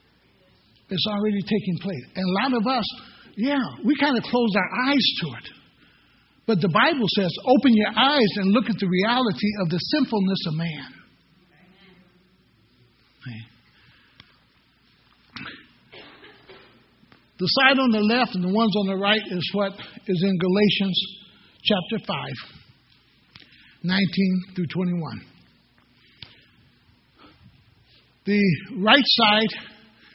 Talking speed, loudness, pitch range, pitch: 120 wpm, -22 LUFS, 180-220 Hz, 200 Hz